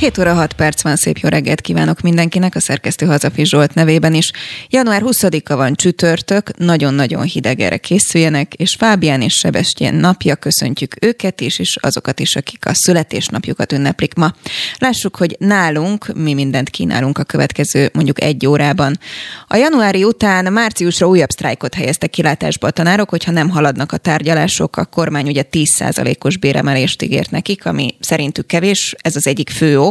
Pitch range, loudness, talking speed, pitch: 145-185 Hz, -13 LUFS, 165 wpm, 160 Hz